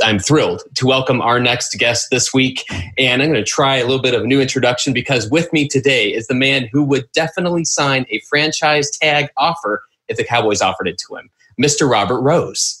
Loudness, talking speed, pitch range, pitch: -15 LUFS, 215 wpm, 125-145 Hz, 135 Hz